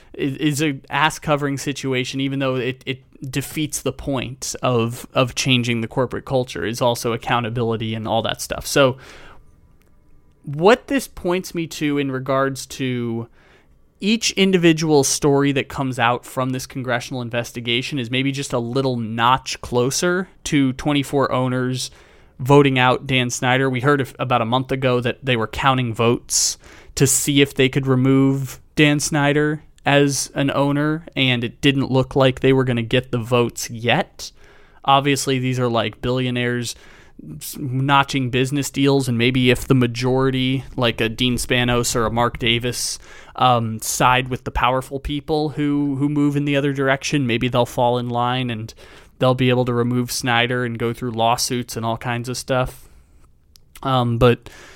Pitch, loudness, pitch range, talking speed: 130 Hz, -19 LUFS, 120-140 Hz, 165 wpm